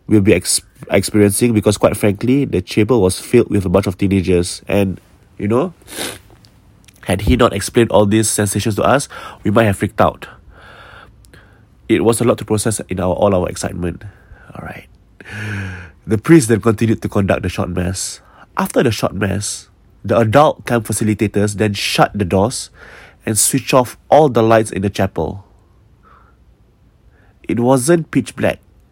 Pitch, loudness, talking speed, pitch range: 105 Hz, -15 LUFS, 165 wpm, 95-115 Hz